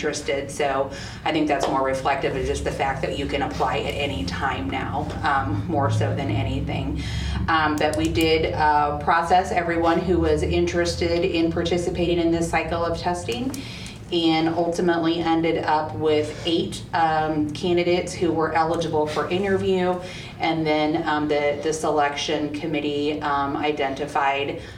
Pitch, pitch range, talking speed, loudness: 155 Hz, 150-170 Hz, 150 wpm, -23 LUFS